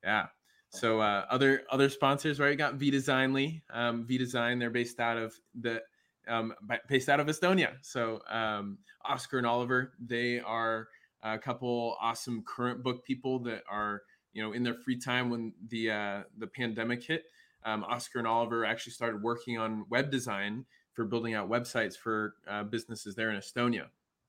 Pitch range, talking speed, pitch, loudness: 110-130 Hz, 175 wpm, 120 Hz, -32 LUFS